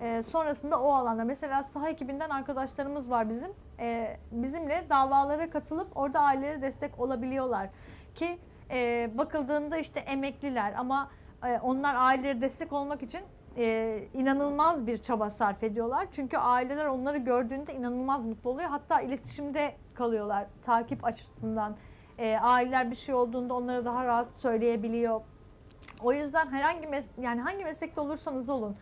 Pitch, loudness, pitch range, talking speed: 270 Hz, -31 LUFS, 240-290 Hz, 135 wpm